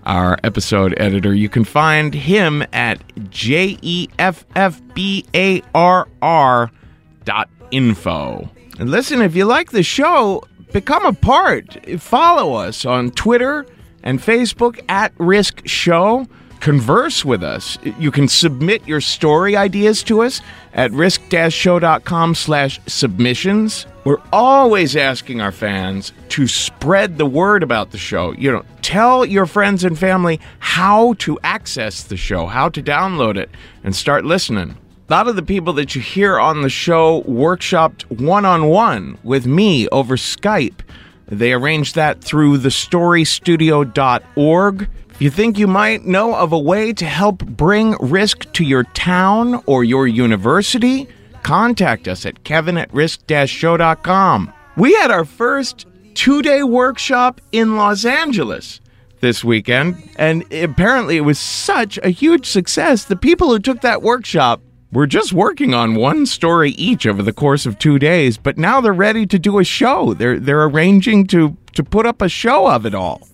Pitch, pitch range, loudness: 165 Hz, 130-205 Hz, -14 LUFS